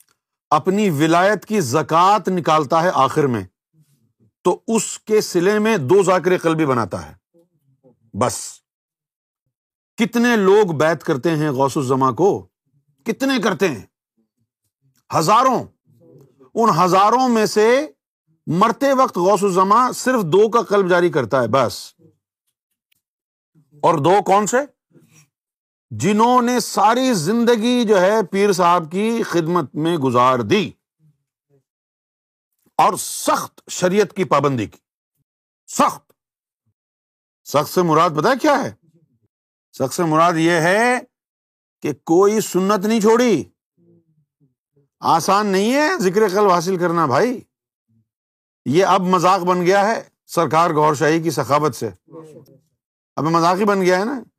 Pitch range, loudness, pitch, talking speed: 145-205 Hz, -17 LUFS, 170 Hz, 125 wpm